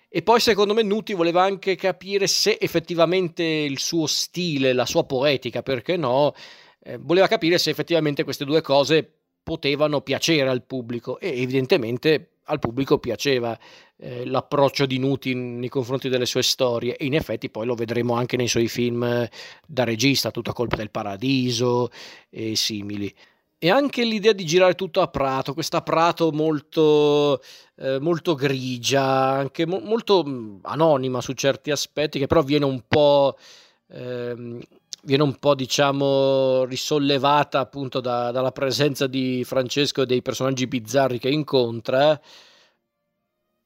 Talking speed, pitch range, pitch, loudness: 145 wpm, 125-160 Hz, 135 Hz, -22 LUFS